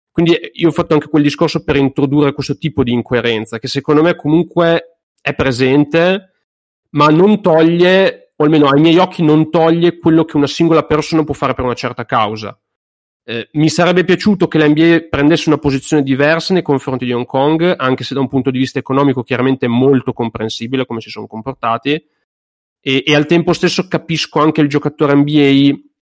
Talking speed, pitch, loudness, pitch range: 185 wpm, 150 Hz, -13 LUFS, 135-165 Hz